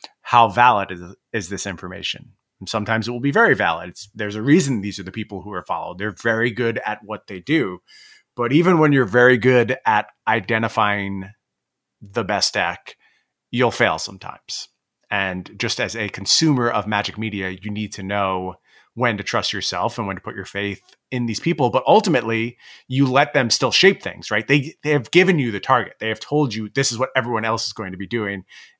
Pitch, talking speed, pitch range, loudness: 110 Hz, 210 wpm, 100-125 Hz, -20 LUFS